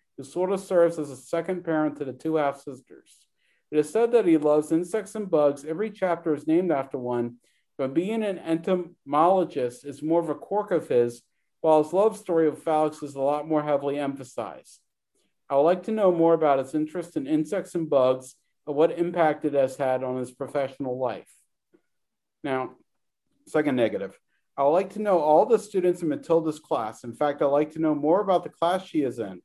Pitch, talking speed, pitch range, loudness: 155 Hz, 210 wpm, 140-175 Hz, -25 LUFS